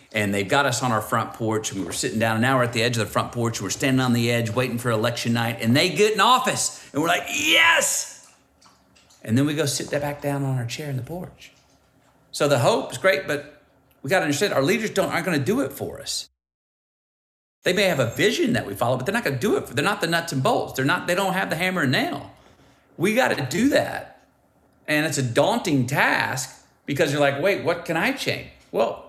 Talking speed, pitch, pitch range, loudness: 255 wpm, 135 Hz, 115-150 Hz, -22 LUFS